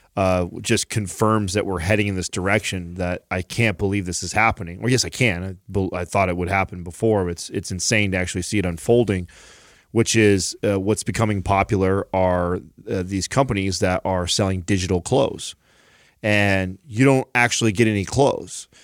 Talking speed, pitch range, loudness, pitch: 190 wpm, 90-110 Hz, -21 LUFS, 95 Hz